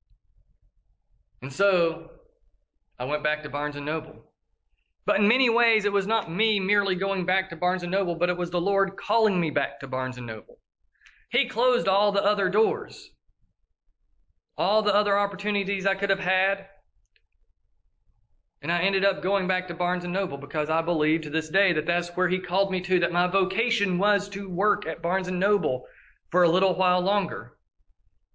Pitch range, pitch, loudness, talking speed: 150-200 Hz, 185 Hz, -25 LUFS, 185 wpm